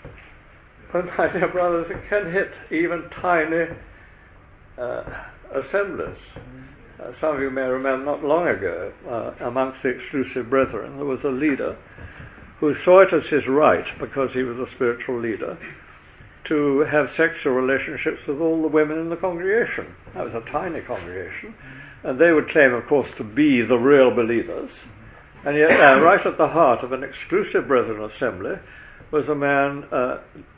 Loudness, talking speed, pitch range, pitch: -21 LUFS, 165 wpm, 130-170 Hz, 145 Hz